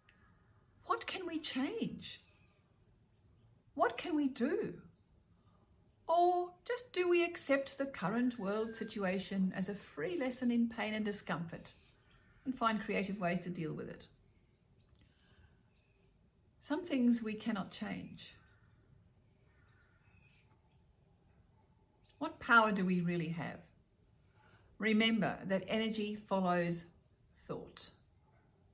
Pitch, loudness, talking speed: 200 Hz, -36 LUFS, 100 wpm